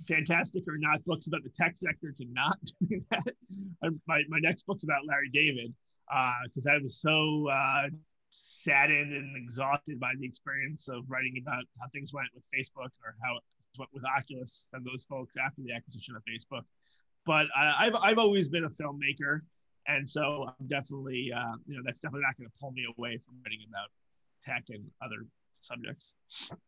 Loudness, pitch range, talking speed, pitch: -31 LUFS, 125-155 Hz, 185 wpm, 140 Hz